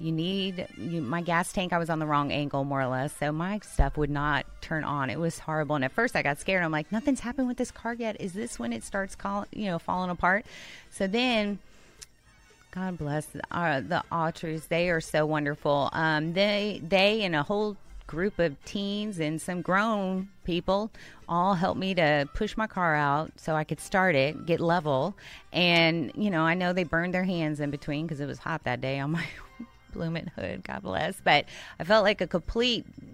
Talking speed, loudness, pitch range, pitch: 215 wpm, -28 LUFS, 150-195 Hz, 170 Hz